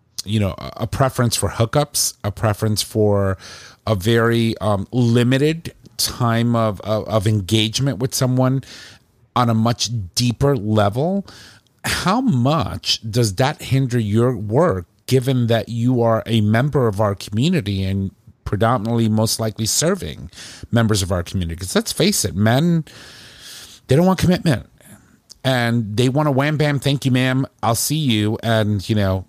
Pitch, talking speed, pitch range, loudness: 115 Hz, 150 wpm, 105-130 Hz, -19 LUFS